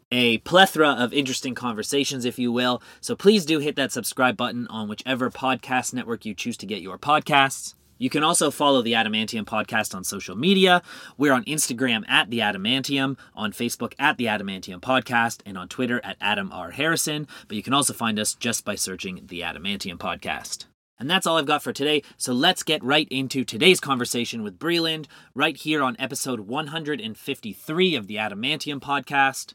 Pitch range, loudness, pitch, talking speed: 115-155 Hz, -23 LUFS, 130 Hz, 185 wpm